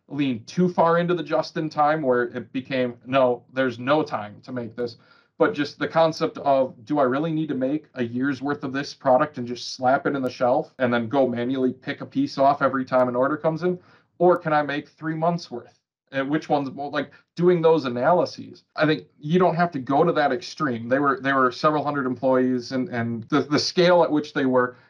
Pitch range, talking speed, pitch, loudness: 125-155 Hz, 235 wpm, 140 Hz, -23 LUFS